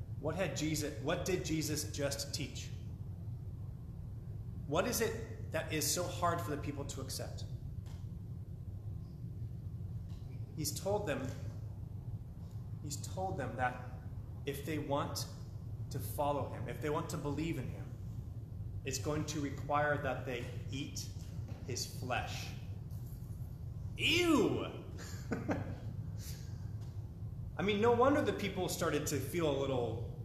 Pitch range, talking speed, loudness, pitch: 110-140 Hz, 120 wpm, -39 LUFS, 120 Hz